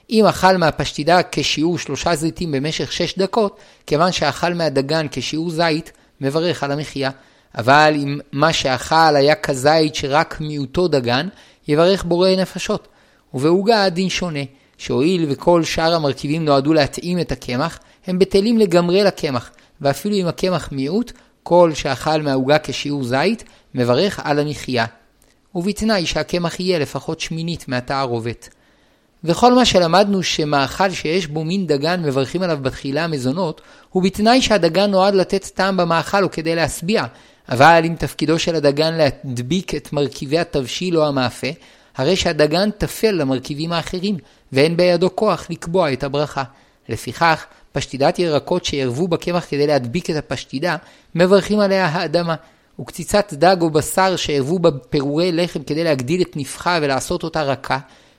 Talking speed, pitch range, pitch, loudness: 135 wpm, 140-180 Hz, 160 Hz, -18 LUFS